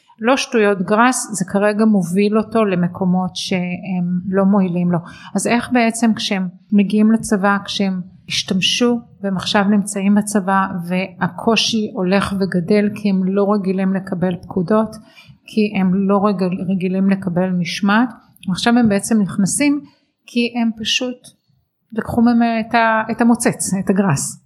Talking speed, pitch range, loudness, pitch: 130 wpm, 190-225 Hz, -17 LUFS, 205 Hz